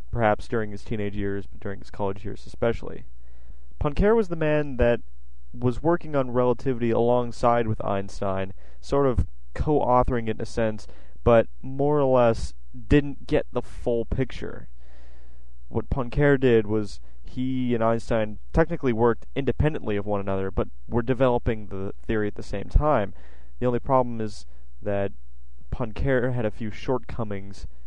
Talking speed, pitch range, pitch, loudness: 155 wpm, 90-125 Hz, 110 Hz, -25 LUFS